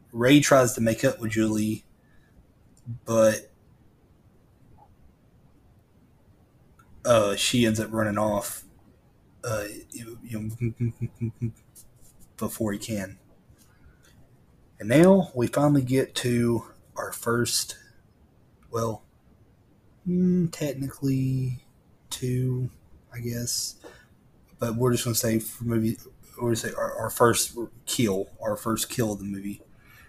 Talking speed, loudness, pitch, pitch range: 100 wpm, -25 LUFS, 115 Hz, 110-125 Hz